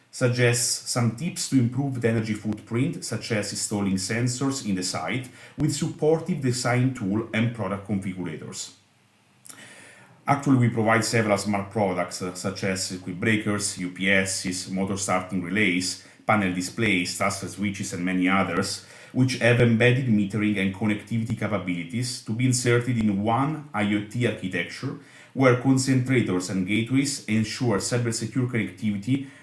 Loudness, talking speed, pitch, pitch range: -24 LUFS, 135 wpm, 110 Hz, 95-125 Hz